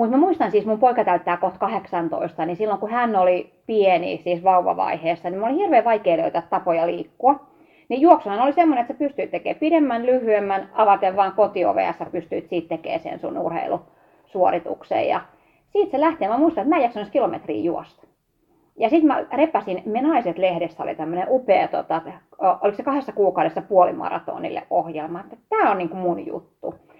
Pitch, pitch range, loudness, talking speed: 210 Hz, 180-275 Hz, -21 LUFS, 170 wpm